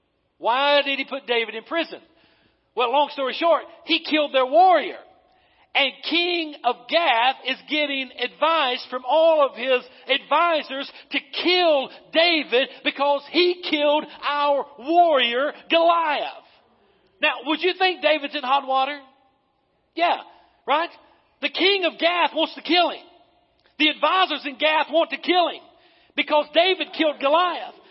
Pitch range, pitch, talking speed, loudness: 275-330 Hz, 300 Hz, 140 wpm, -21 LUFS